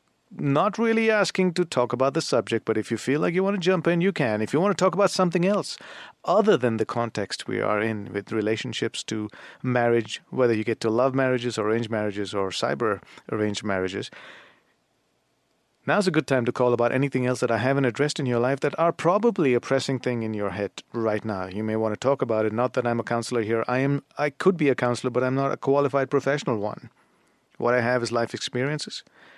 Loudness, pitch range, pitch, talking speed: -24 LUFS, 110-145 Hz, 125 Hz, 230 wpm